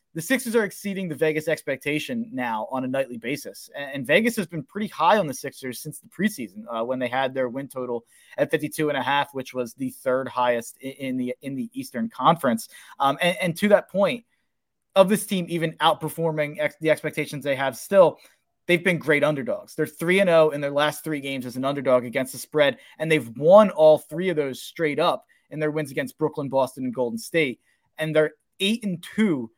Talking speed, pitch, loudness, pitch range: 215 wpm, 150 Hz, -24 LUFS, 135-170 Hz